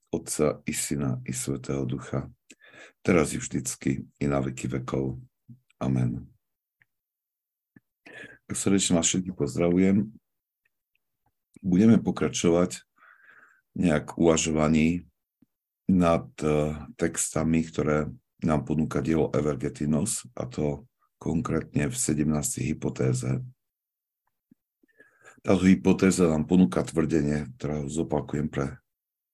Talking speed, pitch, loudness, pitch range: 90 wpm, 75 Hz, -26 LUFS, 70-85 Hz